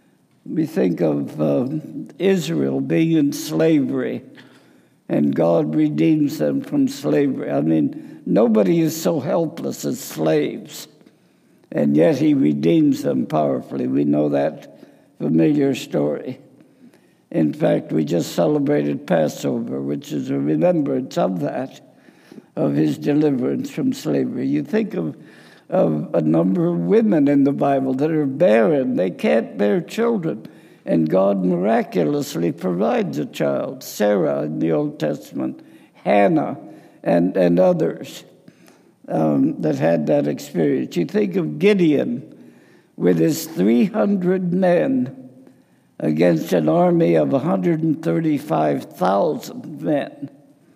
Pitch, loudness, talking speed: 150 Hz, -19 LUFS, 120 wpm